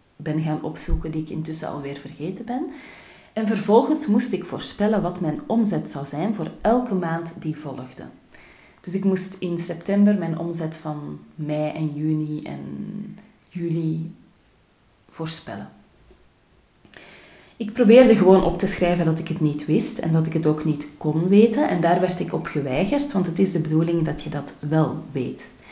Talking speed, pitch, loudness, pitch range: 170 wpm, 165 Hz, -22 LUFS, 155-195 Hz